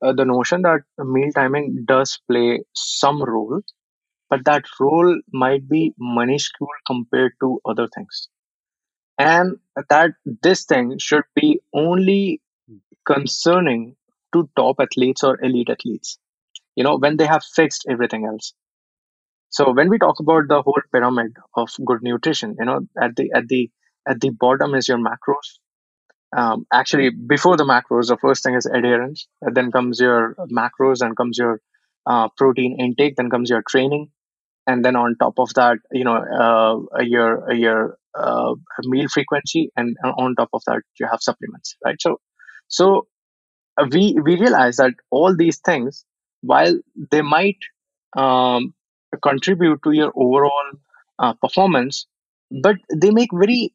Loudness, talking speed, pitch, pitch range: -18 LUFS, 150 wpm, 135 Hz, 125-155 Hz